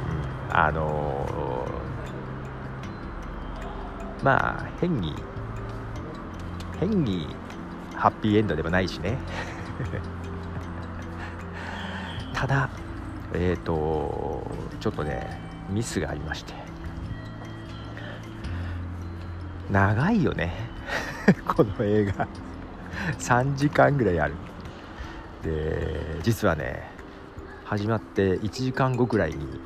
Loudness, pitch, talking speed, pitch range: -28 LUFS, 90 Hz, 140 characters per minute, 80-105 Hz